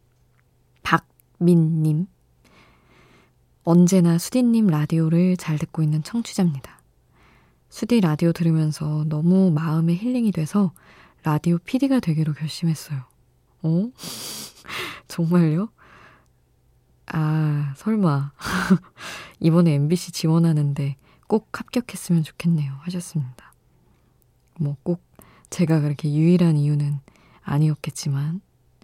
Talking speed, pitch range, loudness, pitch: 225 characters per minute, 150-180 Hz, -22 LUFS, 165 Hz